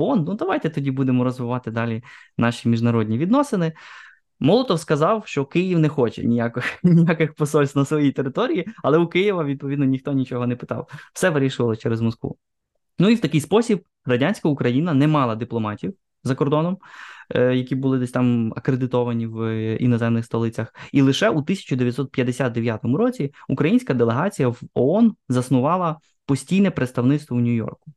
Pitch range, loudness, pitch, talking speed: 120-160 Hz, -21 LUFS, 135 Hz, 145 wpm